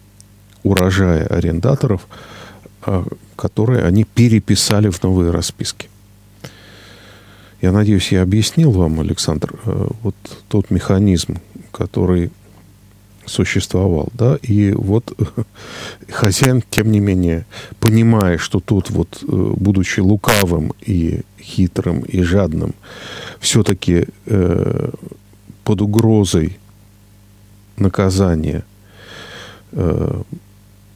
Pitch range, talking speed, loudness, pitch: 95-105 Hz, 80 wpm, -16 LUFS, 100 Hz